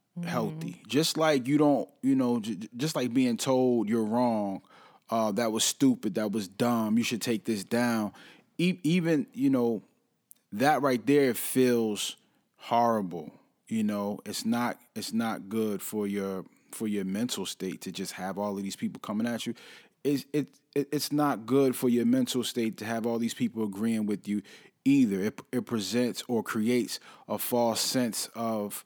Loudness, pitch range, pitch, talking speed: -29 LUFS, 110-140 Hz, 120 Hz, 175 wpm